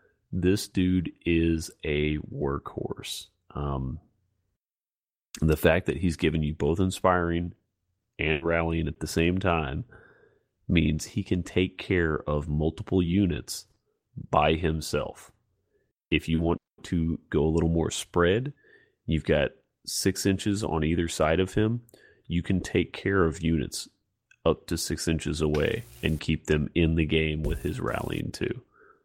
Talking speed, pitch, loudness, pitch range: 145 wpm, 80 Hz, -27 LUFS, 80-90 Hz